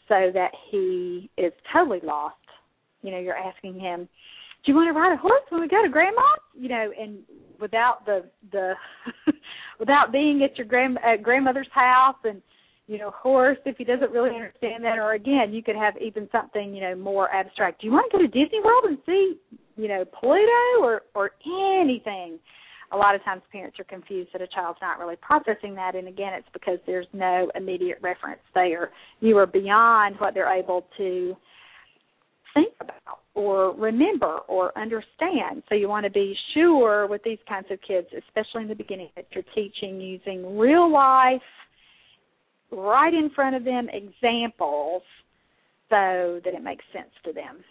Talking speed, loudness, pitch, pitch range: 180 wpm, -23 LUFS, 215 Hz, 190-275 Hz